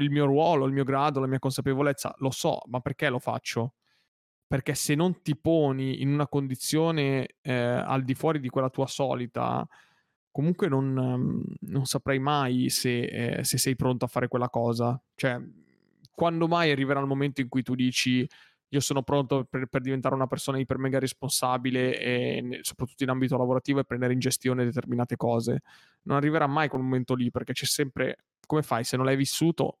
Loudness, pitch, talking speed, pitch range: -27 LUFS, 135 Hz, 185 wpm, 125-145 Hz